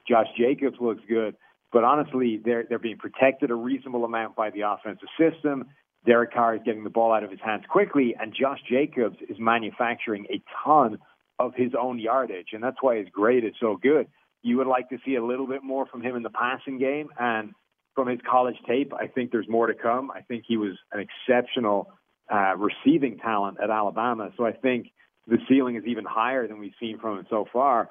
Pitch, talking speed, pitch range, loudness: 120 Hz, 215 wpm, 110-130 Hz, -25 LUFS